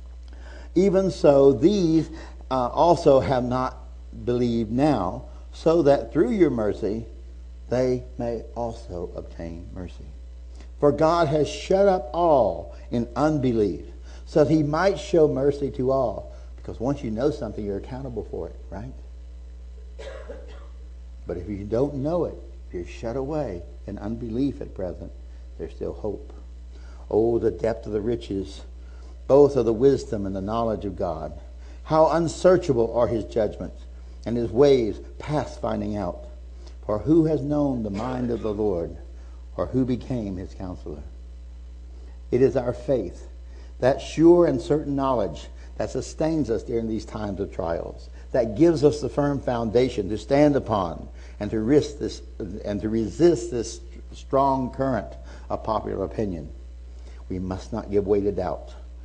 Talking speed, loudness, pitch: 150 wpm, -24 LUFS, 105 Hz